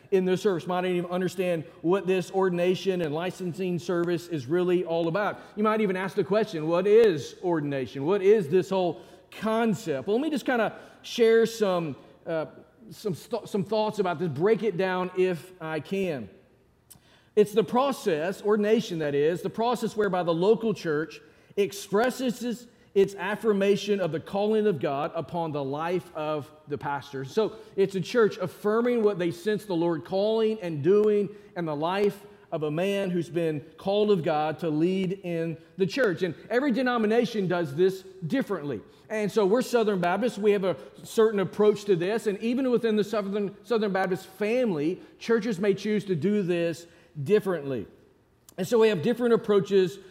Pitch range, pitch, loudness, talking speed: 170-215 Hz, 190 Hz, -26 LUFS, 175 wpm